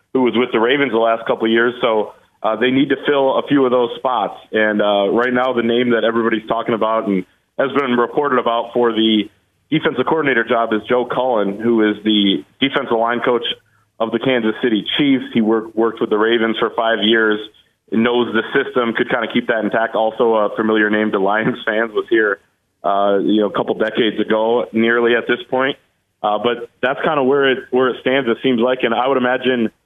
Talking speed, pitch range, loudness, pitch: 225 wpm, 110-125 Hz, -17 LUFS, 115 Hz